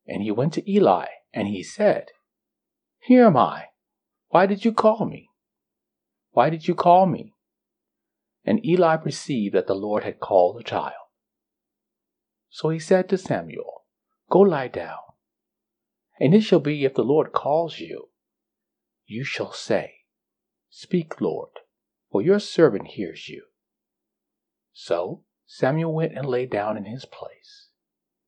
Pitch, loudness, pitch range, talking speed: 170 Hz, -22 LUFS, 145-210 Hz, 140 wpm